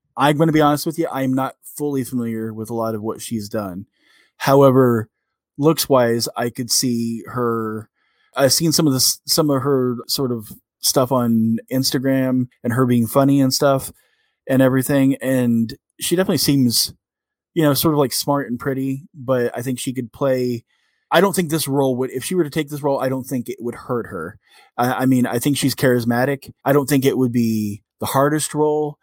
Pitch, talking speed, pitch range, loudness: 130 Hz, 205 wpm, 120-140 Hz, -19 LUFS